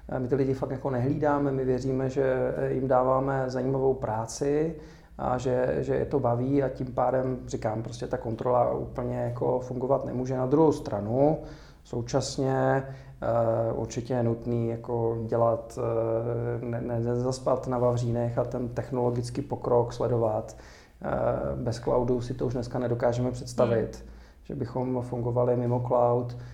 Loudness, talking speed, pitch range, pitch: -28 LUFS, 140 wpm, 120-130 Hz, 125 Hz